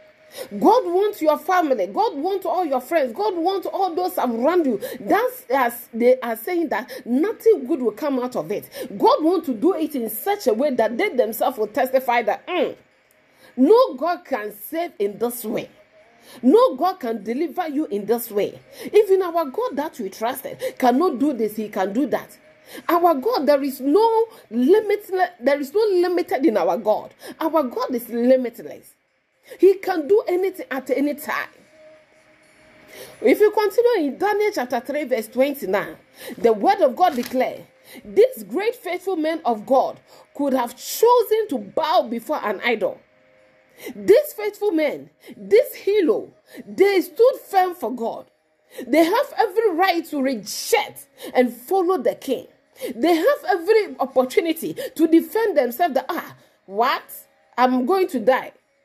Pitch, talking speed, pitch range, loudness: 320 Hz, 160 wpm, 255-390 Hz, -21 LUFS